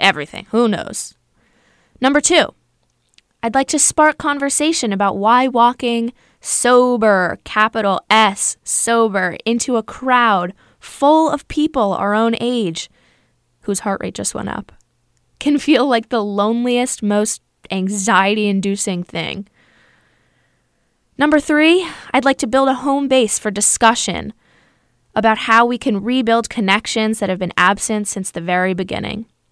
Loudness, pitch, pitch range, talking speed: -16 LUFS, 225 Hz, 200-255 Hz, 135 wpm